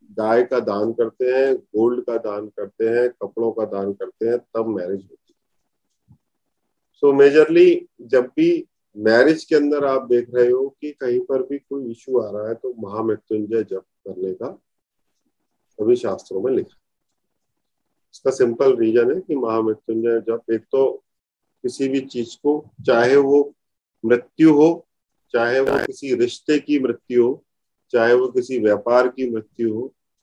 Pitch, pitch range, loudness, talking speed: 125 Hz, 115-155 Hz, -19 LUFS, 160 wpm